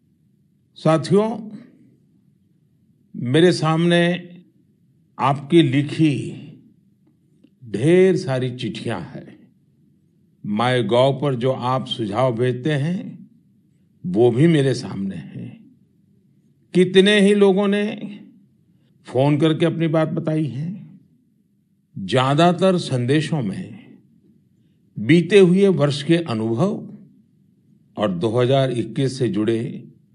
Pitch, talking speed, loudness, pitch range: 165 Hz, 90 wpm, -19 LUFS, 135-190 Hz